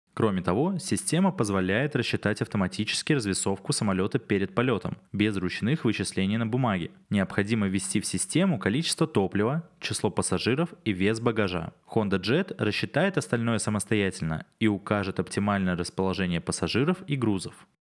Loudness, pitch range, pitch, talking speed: -27 LUFS, 95-120 Hz, 105 Hz, 130 wpm